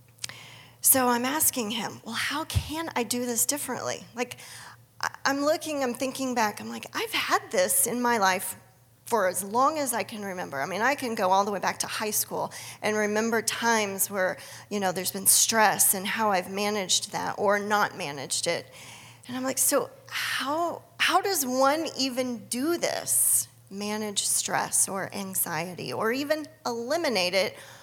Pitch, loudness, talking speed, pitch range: 210 Hz, -26 LUFS, 175 wpm, 185-255 Hz